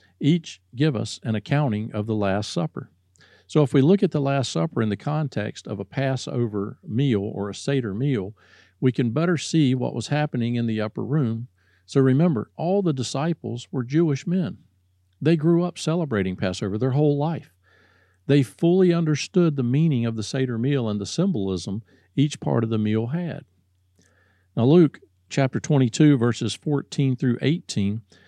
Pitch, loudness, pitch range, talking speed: 130 Hz, -23 LUFS, 105-150 Hz, 175 wpm